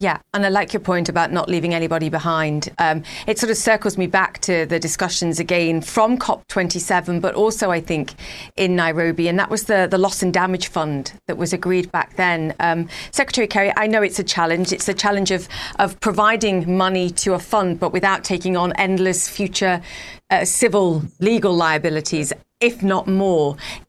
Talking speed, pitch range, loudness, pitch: 190 wpm, 170-200 Hz, -19 LUFS, 185 Hz